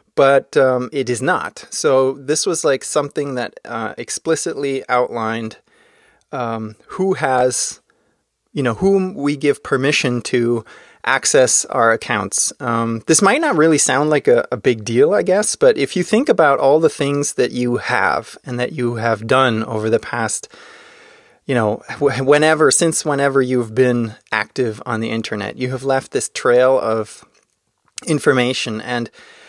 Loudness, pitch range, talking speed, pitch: -17 LUFS, 120-150 Hz, 160 wpm, 130 Hz